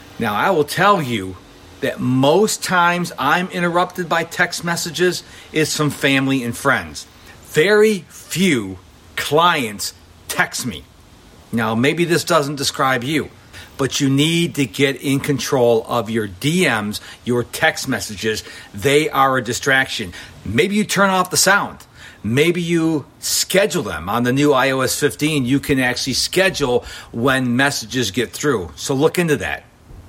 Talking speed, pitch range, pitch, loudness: 145 wpm, 115-160 Hz, 140 Hz, -18 LUFS